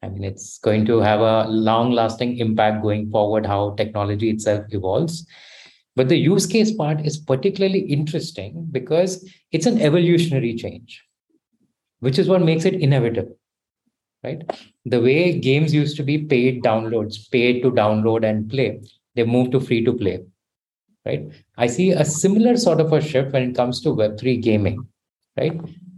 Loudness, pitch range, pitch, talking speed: -19 LUFS, 110-160 Hz, 125 Hz, 165 wpm